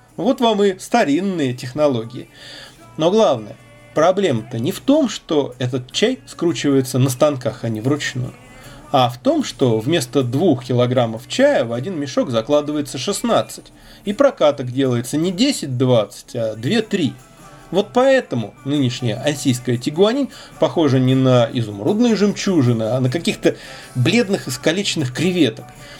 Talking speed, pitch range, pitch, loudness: 130 wpm, 125-195 Hz, 140 Hz, -18 LUFS